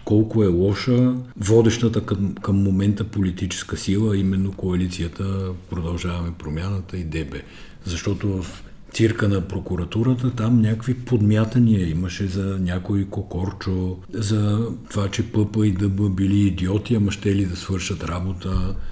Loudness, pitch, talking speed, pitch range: -22 LUFS, 100 Hz, 130 wpm, 90-105 Hz